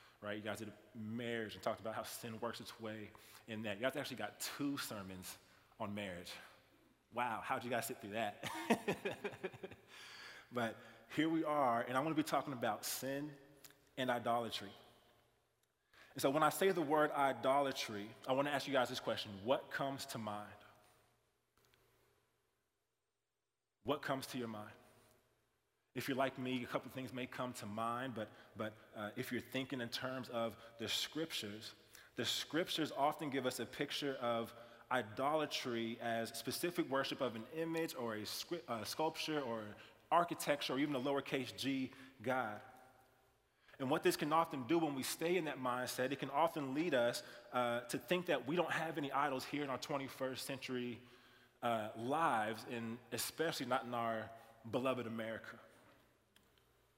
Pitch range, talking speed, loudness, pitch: 115-140 Hz, 170 wpm, -41 LUFS, 125 Hz